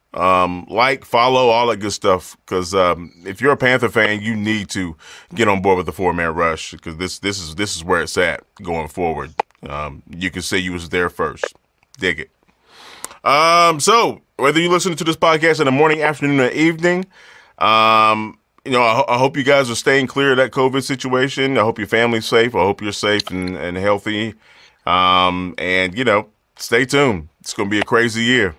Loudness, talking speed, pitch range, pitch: -16 LUFS, 210 wpm, 90-135 Hz, 110 Hz